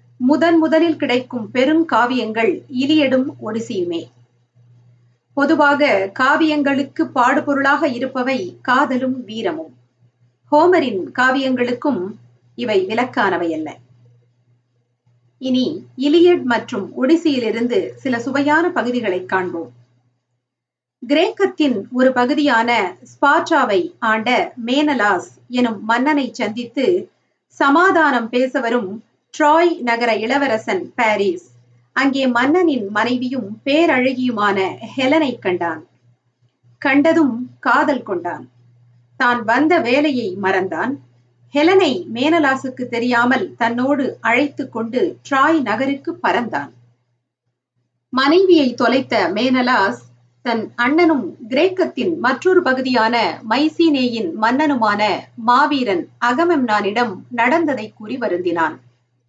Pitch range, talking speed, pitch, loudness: 185-290 Hz, 80 wpm, 245 Hz, -17 LUFS